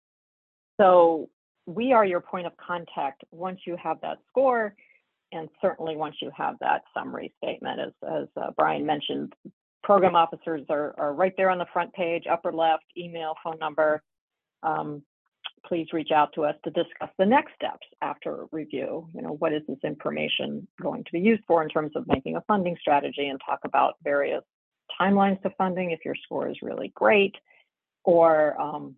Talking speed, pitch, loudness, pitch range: 180 wpm, 165 Hz, -26 LUFS, 155-185 Hz